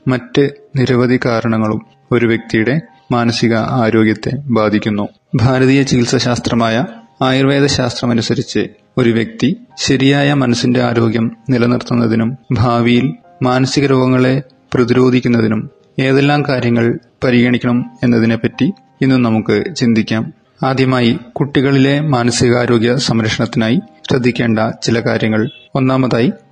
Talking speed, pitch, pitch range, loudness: 85 wpm, 125 Hz, 115-130 Hz, -14 LUFS